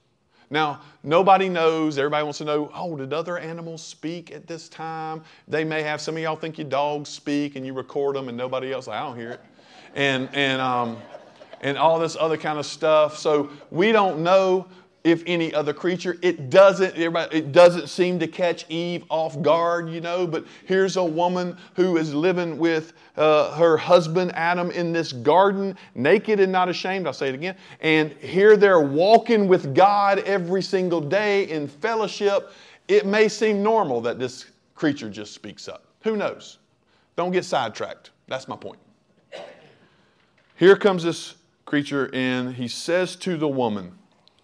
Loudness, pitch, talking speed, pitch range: -21 LUFS, 165 Hz, 175 wpm, 150-185 Hz